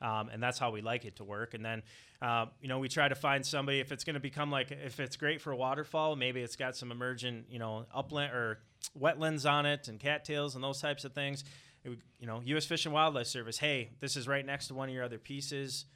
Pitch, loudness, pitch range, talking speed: 135 Hz, -35 LUFS, 120-145 Hz, 260 wpm